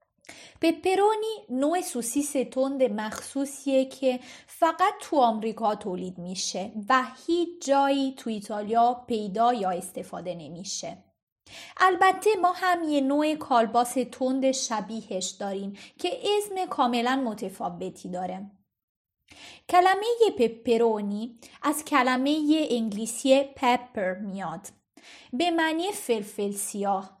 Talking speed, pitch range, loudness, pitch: 100 wpm, 210-300 Hz, -26 LUFS, 250 Hz